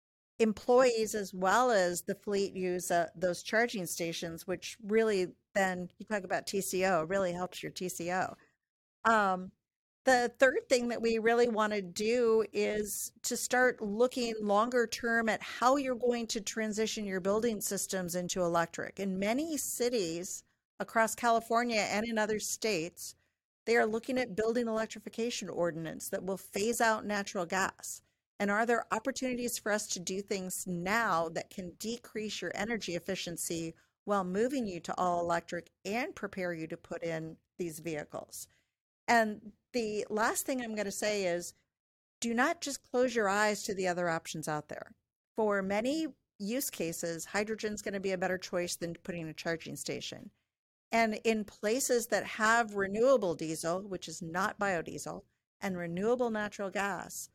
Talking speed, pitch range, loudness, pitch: 160 wpm, 180-230 Hz, -33 LUFS, 205 Hz